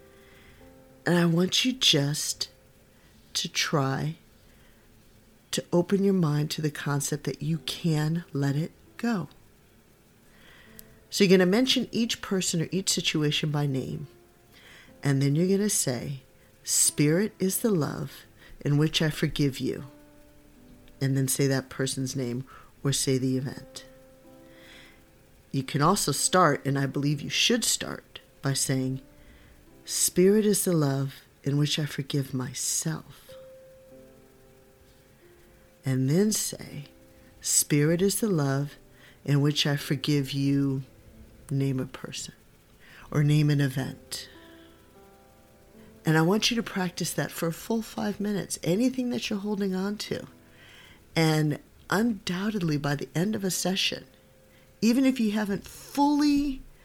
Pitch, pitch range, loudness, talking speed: 145 Hz, 130-185 Hz, -26 LUFS, 135 wpm